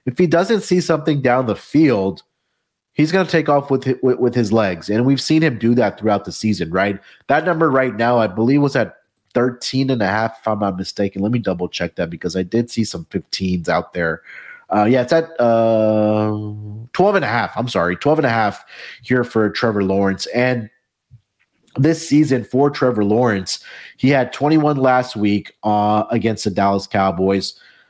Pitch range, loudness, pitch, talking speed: 105-135 Hz, -17 LUFS, 115 Hz, 200 wpm